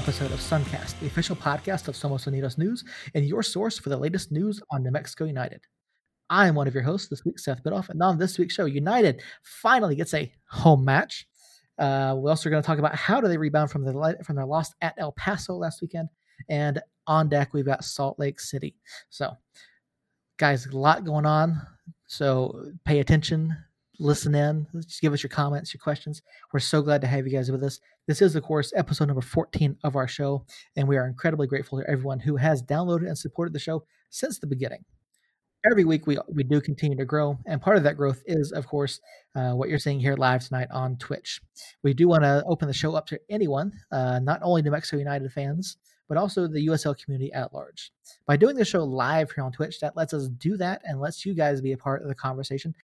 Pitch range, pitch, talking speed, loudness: 140-160 Hz, 150 Hz, 225 wpm, -26 LUFS